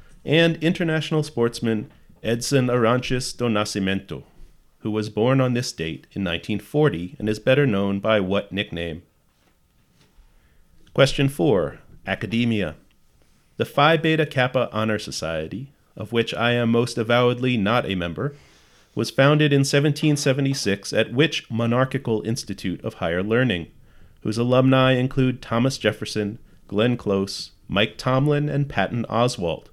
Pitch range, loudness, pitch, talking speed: 100-130 Hz, -22 LUFS, 115 Hz, 125 wpm